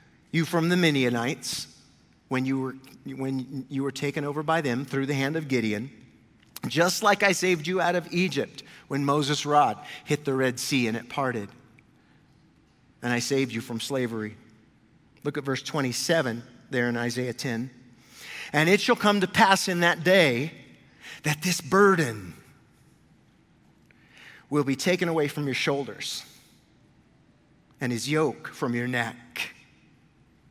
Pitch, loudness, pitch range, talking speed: 140 Hz, -26 LUFS, 125-165 Hz, 150 wpm